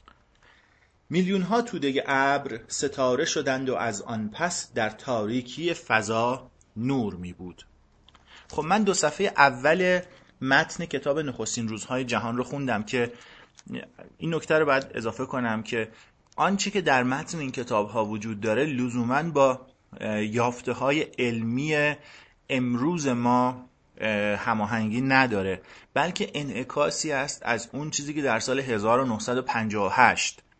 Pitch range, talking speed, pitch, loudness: 115-145 Hz, 125 wpm, 125 Hz, -26 LUFS